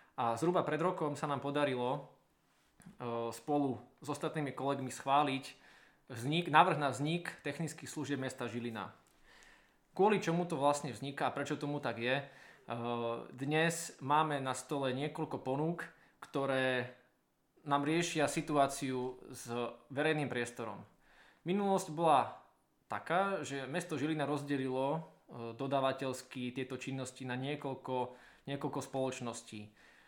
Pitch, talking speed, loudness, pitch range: 140 Hz, 115 wpm, -36 LUFS, 130-150 Hz